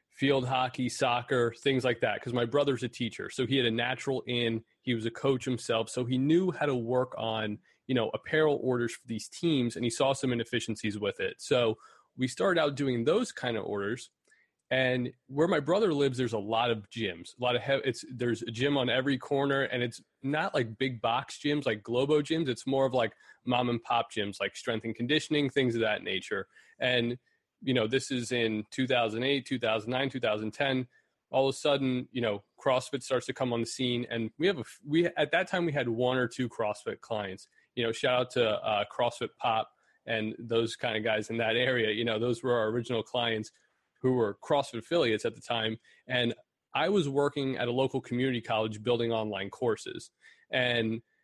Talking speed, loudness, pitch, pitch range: 210 wpm, -30 LUFS, 125 Hz, 115-135 Hz